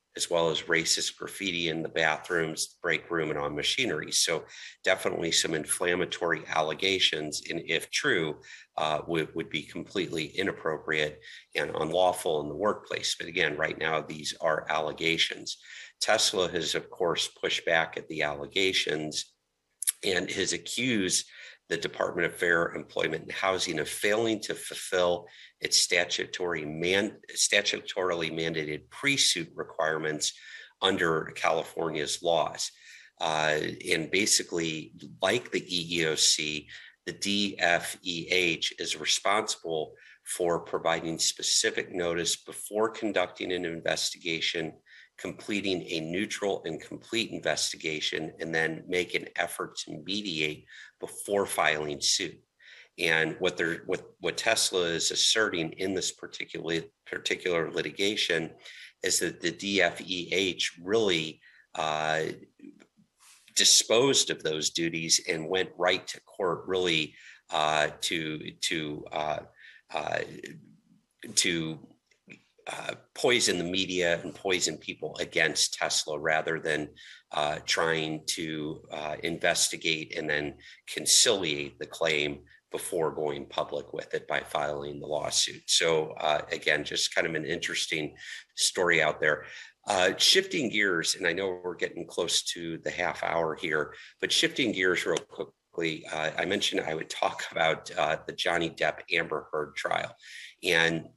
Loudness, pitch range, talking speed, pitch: -28 LUFS, 75-95 Hz, 130 wpm, 80 Hz